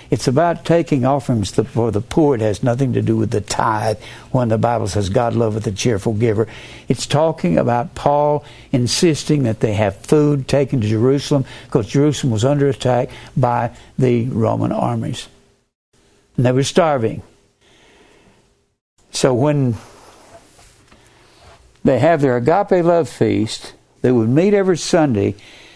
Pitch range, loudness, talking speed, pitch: 115-145 Hz, -17 LUFS, 145 wpm, 125 Hz